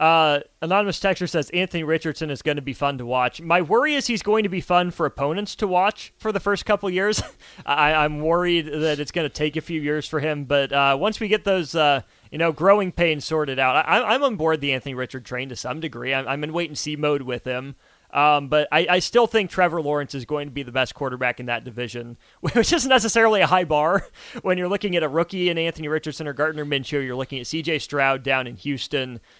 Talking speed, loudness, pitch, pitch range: 245 wpm, -22 LUFS, 155 Hz, 140-180 Hz